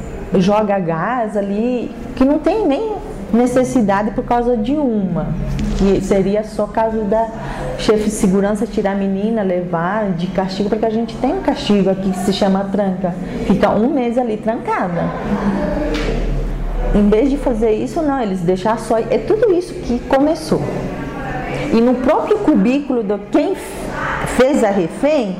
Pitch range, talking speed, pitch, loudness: 200-255 Hz, 155 wpm, 220 Hz, -17 LUFS